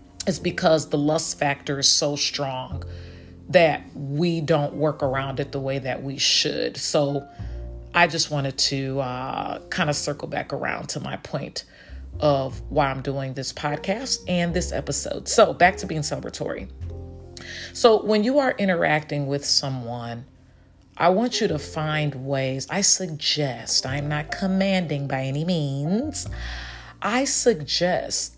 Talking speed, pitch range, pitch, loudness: 150 wpm, 130-170 Hz, 145 Hz, -23 LUFS